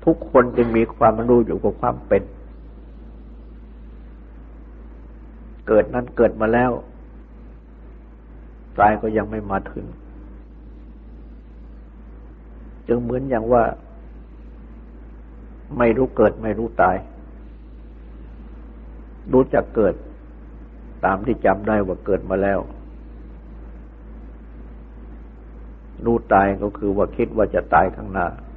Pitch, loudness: 95 Hz, -20 LUFS